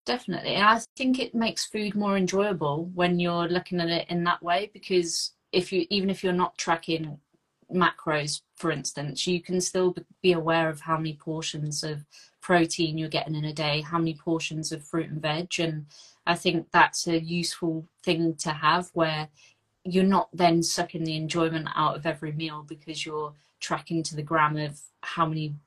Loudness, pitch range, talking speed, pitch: -27 LUFS, 155-180 Hz, 185 wpm, 165 Hz